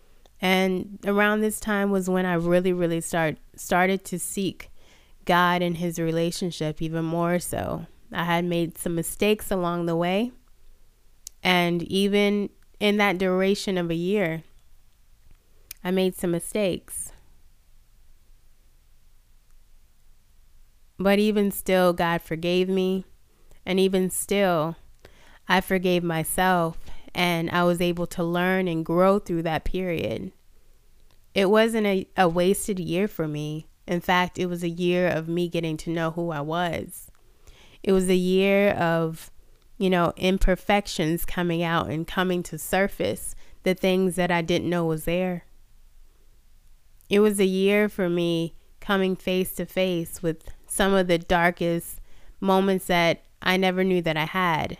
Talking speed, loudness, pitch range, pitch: 140 wpm, -24 LUFS, 170-190 Hz, 180 Hz